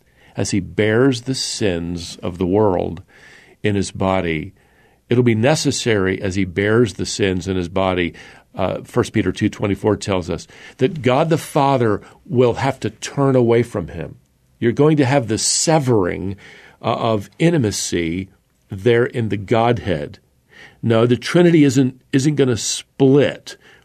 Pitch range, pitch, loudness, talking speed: 95-130 Hz, 110 Hz, -18 LUFS, 165 wpm